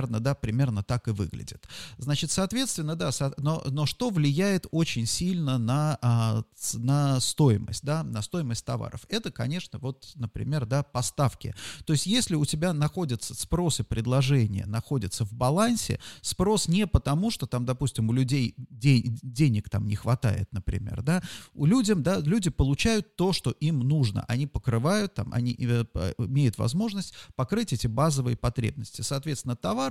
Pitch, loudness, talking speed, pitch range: 135 Hz, -27 LUFS, 155 wpm, 120-160 Hz